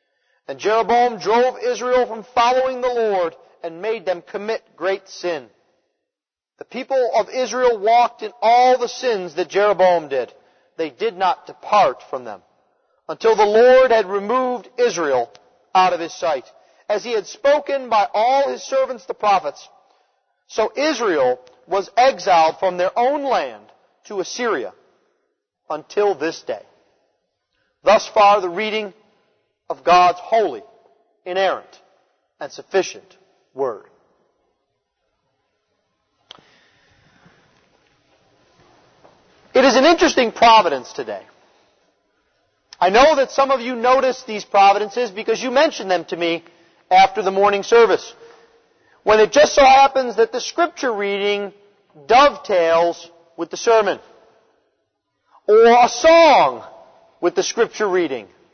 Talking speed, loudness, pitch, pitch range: 125 wpm, -17 LUFS, 230 Hz, 195-265 Hz